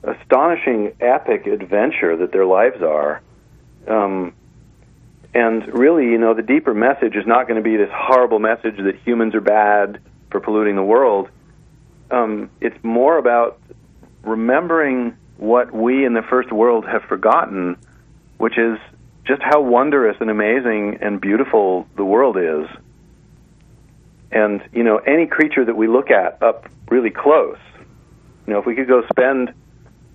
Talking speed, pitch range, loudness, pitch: 150 wpm, 110-130 Hz, -16 LUFS, 115 Hz